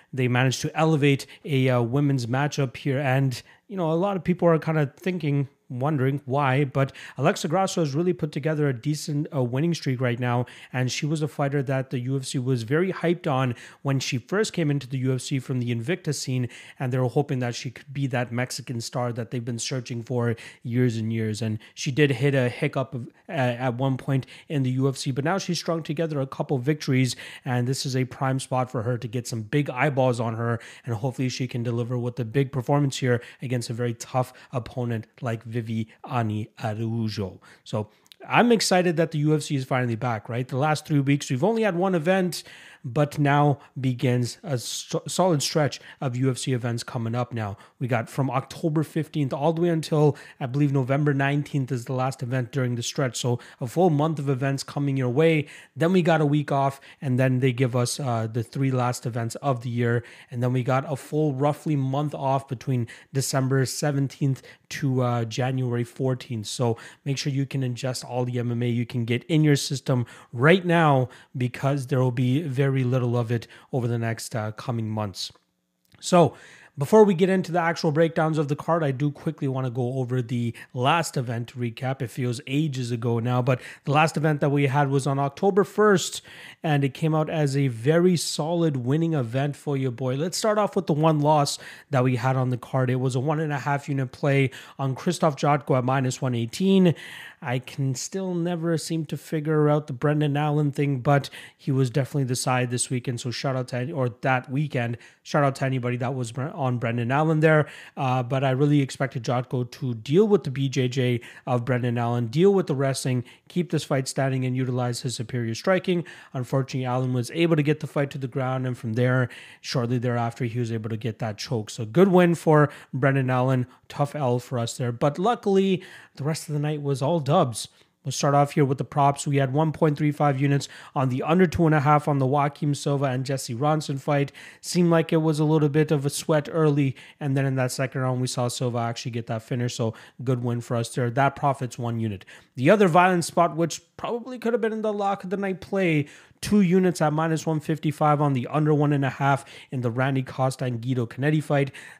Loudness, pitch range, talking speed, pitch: -25 LUFS, 125-150 Hz, 215 wpm, 135 Hz